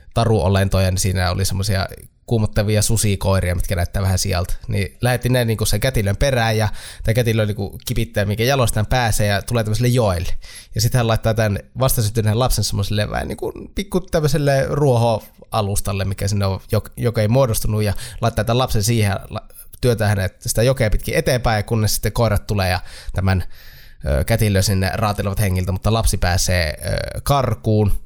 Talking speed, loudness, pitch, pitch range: 160 wpm, -19 LUFS, 105 Hz, 95-115 Hz